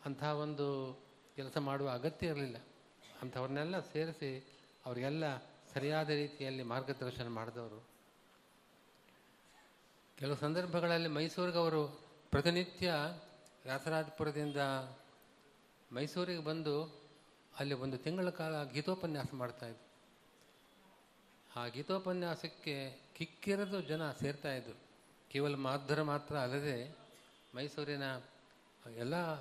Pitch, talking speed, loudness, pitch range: 145 Hz, 75 wpm, -40 LUFS, 135-155 Hz